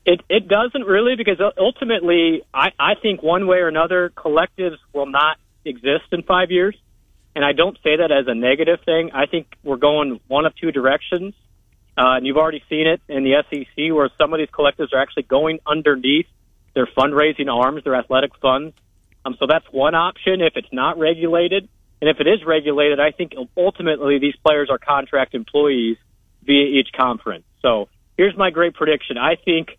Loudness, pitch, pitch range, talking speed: -18 LUFS, 150 Hz, 135-170 Hz, 185 wpm